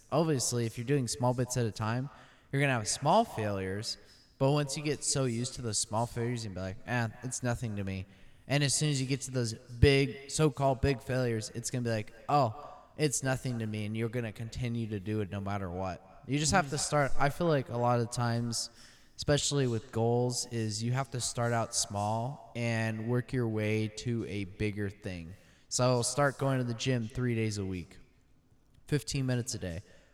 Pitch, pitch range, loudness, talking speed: 120 Hz, 110-135 Hz, -32 LUFS, 215 wpm